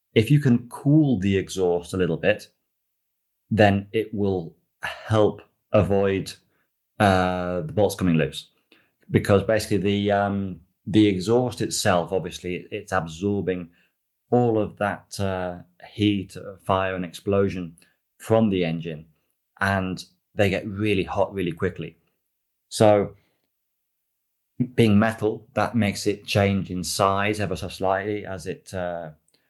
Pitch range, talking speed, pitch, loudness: 90-105 Hz, 125 wpm, 100 Hz, -23 LUFS